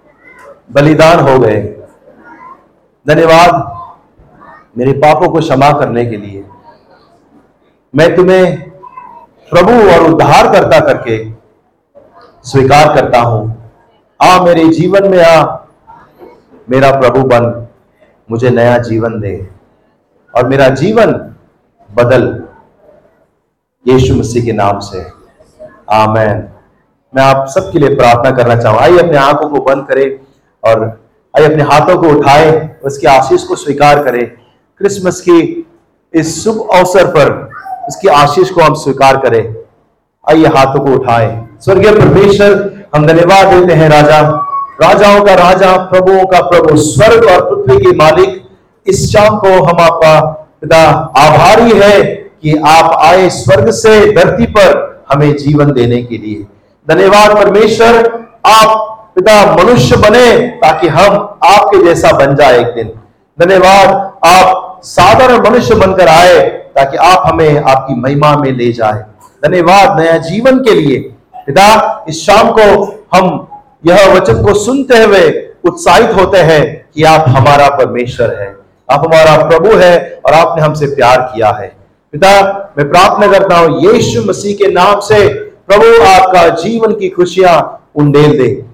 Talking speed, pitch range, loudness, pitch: 135 wpm, 130-195 Hz, -6 LUFS, 160 Hz